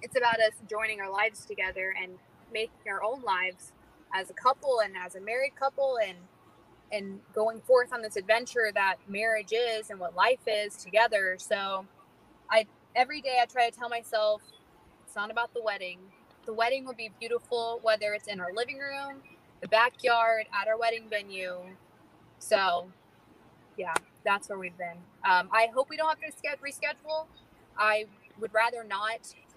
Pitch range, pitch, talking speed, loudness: 195-240 Hz, 220 Hz, 170 wpm, -29 LUFS